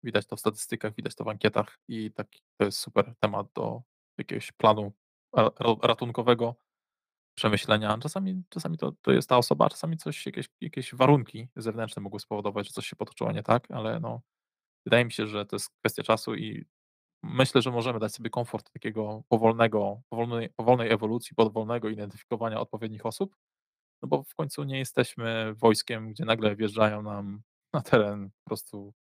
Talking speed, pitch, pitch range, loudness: 170 wpm, 110 Hz, 105-120 Hz, -28 LUFS